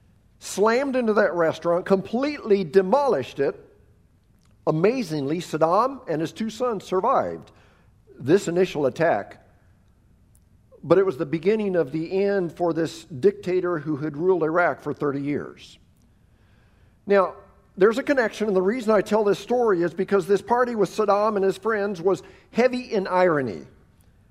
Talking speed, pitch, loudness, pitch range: 145 wpm, 180 Hz, -23 LUFS, 145-210 Hz